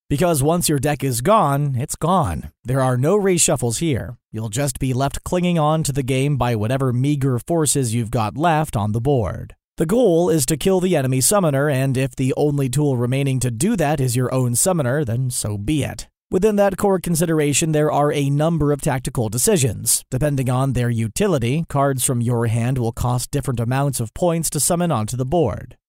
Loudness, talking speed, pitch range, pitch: -19 LUFS, 200 wpm, 125-155 Hz, 140 Hz